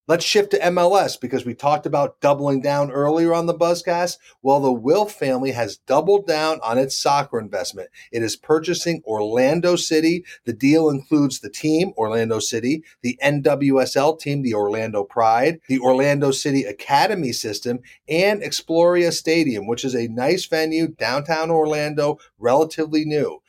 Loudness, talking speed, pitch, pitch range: -20 LUFS, 155 wpm, 145 Hz, 130-165 Hz